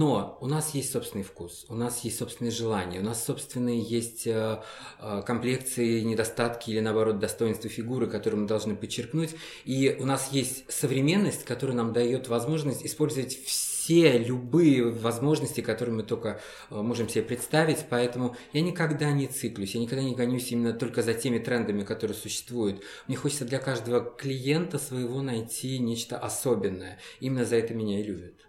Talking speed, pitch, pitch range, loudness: 160 wpm, 120 Hz, 115-135 Hz, -28 LUFS